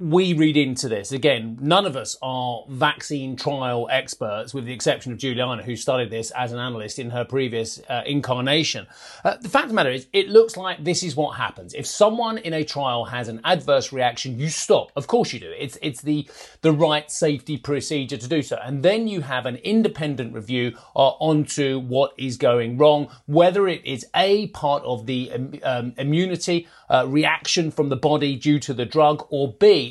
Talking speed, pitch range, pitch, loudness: 200 wpm, 125-155 Hz, 140 Hz, -22 LUFS